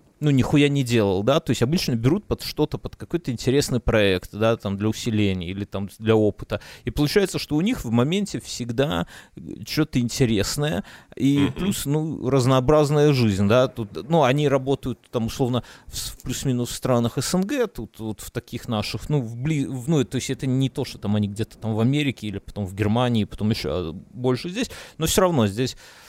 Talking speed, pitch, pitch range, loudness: 190 wpm, 125 Hz, 110-145 Hz, -23 LUFS